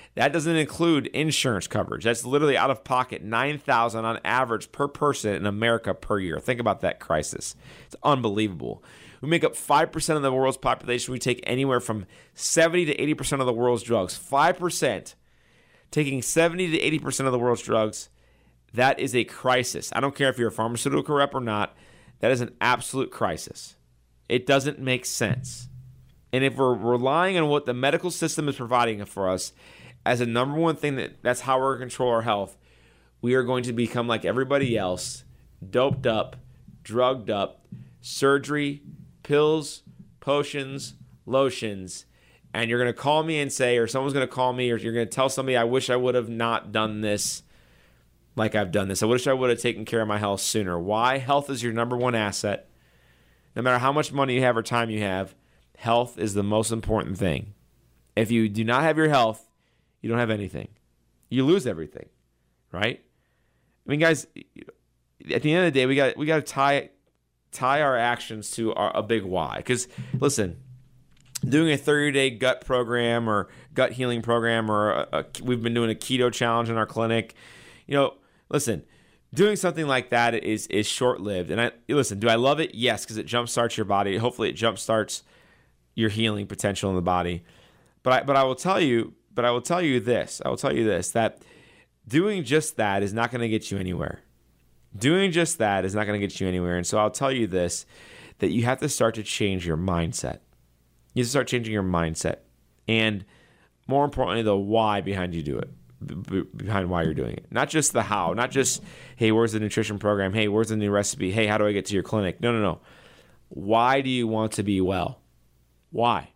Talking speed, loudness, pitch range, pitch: 200 wpm, -25 LUFS, 105-135 Hz, 120 Hz